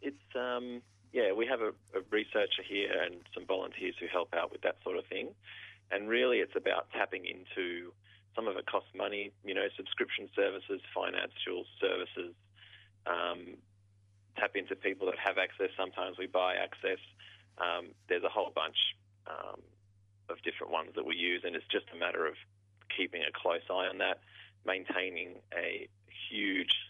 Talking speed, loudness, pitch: 165 wpm, -35 LUFS, 100 Hz